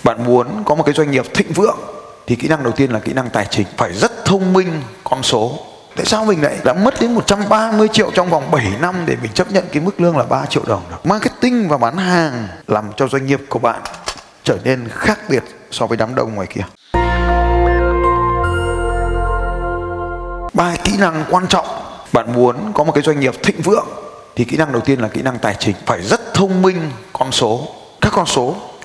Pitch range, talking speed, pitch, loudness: 120-185 Hz, 215 wpm, 155 Hz, -16 LUFS